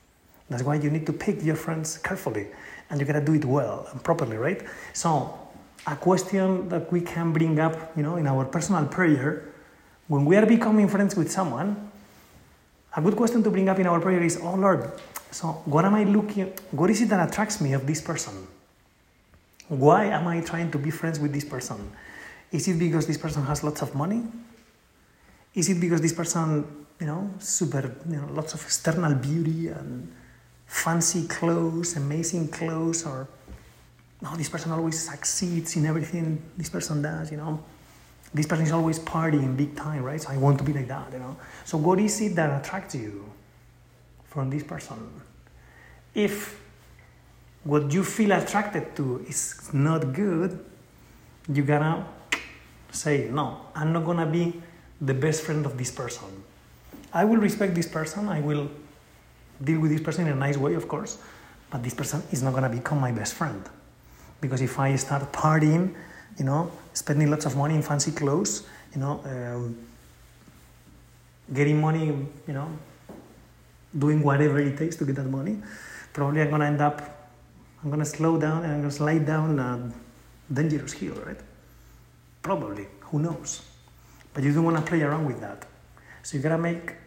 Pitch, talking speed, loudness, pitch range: 155 Hz, 175 wpm, -26 LUFS, 140-170 Hz